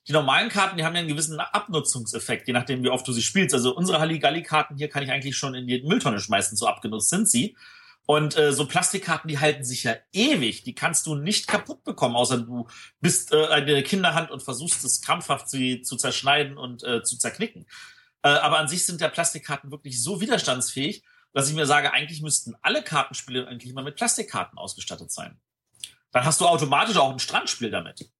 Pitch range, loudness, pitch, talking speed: 130-170 Hz, -23 LUFS, 150 Hz, 205 wpm